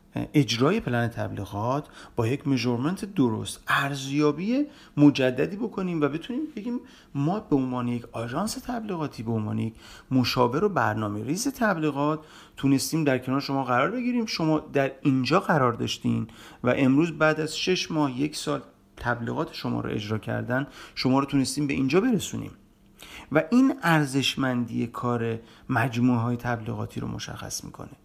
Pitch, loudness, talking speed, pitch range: 135 Hz, -26 LUFS, 145 wpm, 120-155 Hz